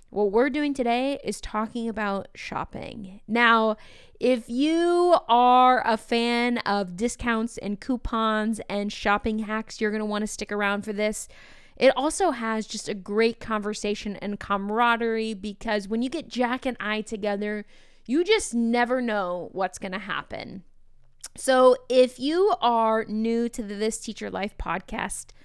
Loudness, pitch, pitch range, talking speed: -25 LUFS, 225 Hz, 210-245 Hz, 155 wpm